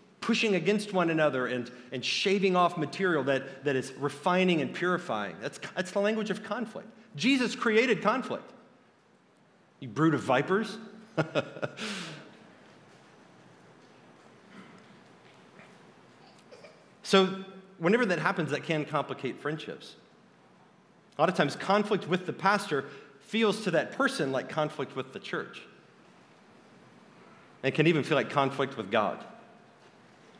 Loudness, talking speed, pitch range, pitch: -29 LUFS, 120 wpm, 140-205 Hz, 180 Hz